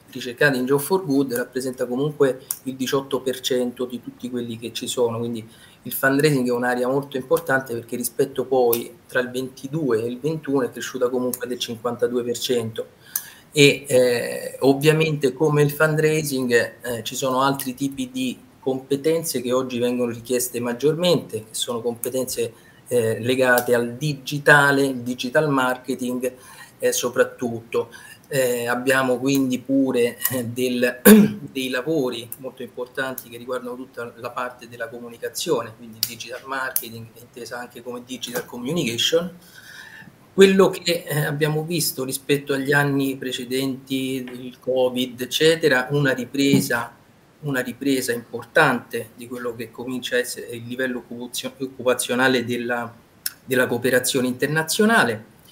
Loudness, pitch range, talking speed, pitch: -22 LUFS, 125-145 Hz, 130 wpm, 130 Hz